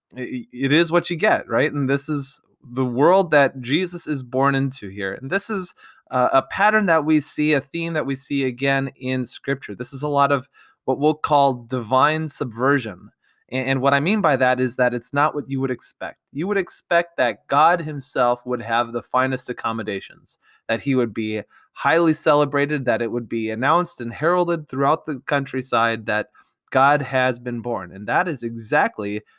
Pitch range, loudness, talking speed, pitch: 125-150 Hz, -21 LUFS, 195 wpm, 135 Hz